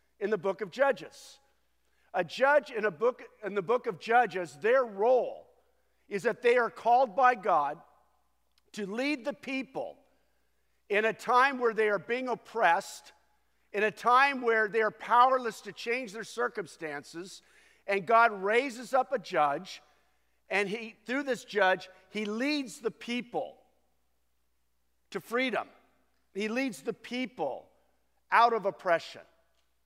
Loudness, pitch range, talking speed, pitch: -29 LUFS, 195-245 Hz, 145 wpm, 225 Hz